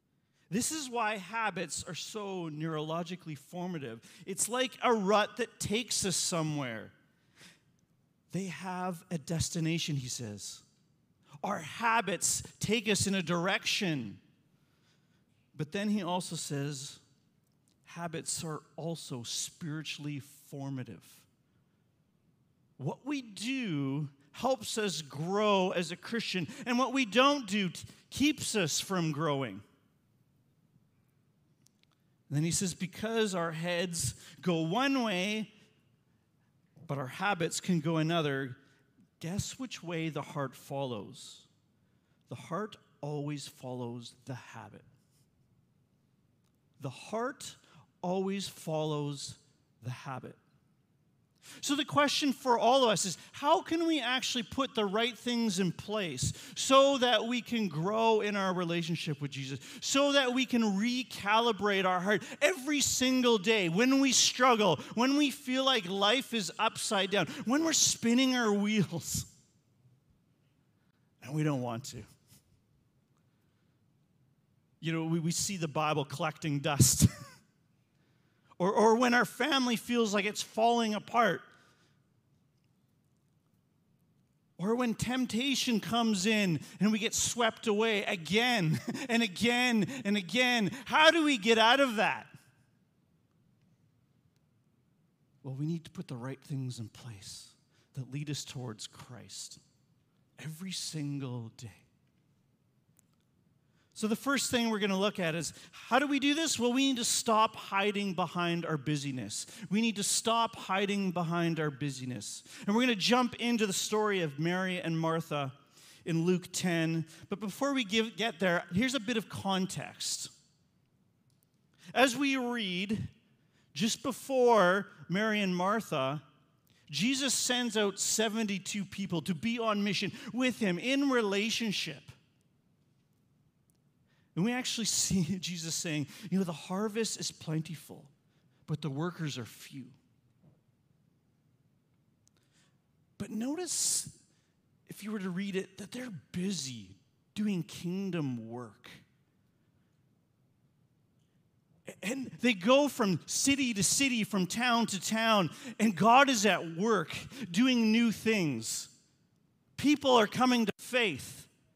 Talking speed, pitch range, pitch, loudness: 125 wpm, 145-220 Hz, 175 Hz, -31 LUFS